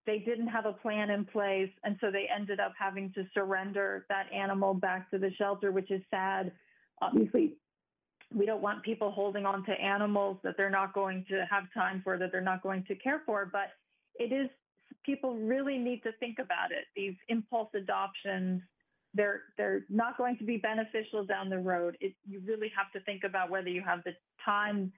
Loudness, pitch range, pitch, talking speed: -34 LUFS, 195-220 Hz, 200 Hz, 205 wpm